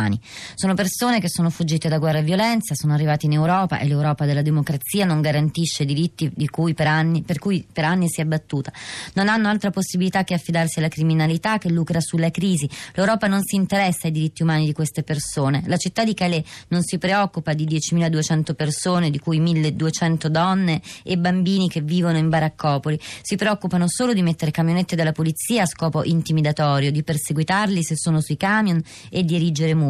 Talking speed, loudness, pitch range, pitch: 190 wpm, -21 LUFS, 155-180 Hz, 165 Hz